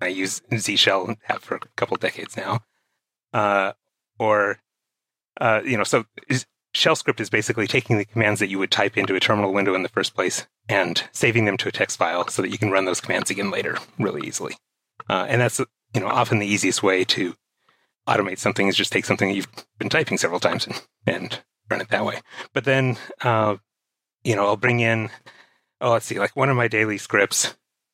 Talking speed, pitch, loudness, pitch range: 215 wpm, 105 Hz, -22 LUFS, 100-115 Hz